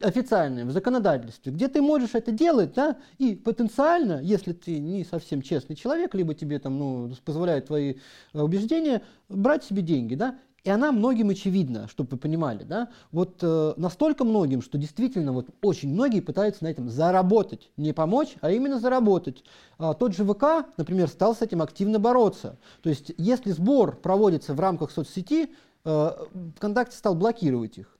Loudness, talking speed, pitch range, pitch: -25 LUFS, 165 wpm, 155-240 Hz, 190 Hz